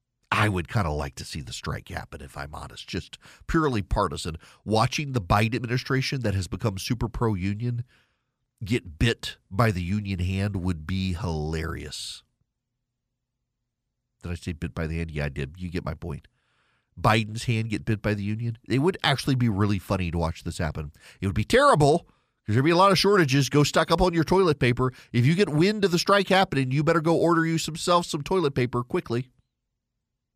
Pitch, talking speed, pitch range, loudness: 120 Hz, 205 wpm, 95-130 Hz, -25 LUFS